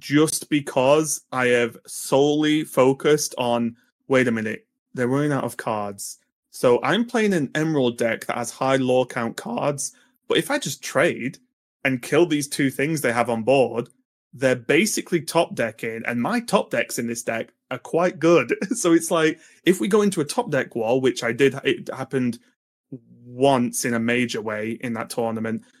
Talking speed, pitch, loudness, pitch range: 185 wpm, 135 Hz, -22 LUFS, 120-155 Hz